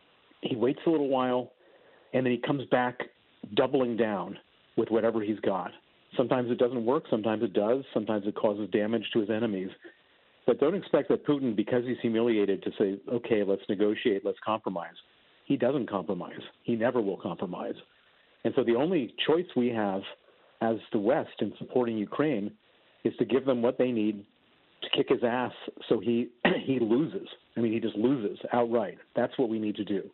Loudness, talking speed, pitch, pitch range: -29 LUFS, 185 wpm, 115 Hz, 105-125 Hz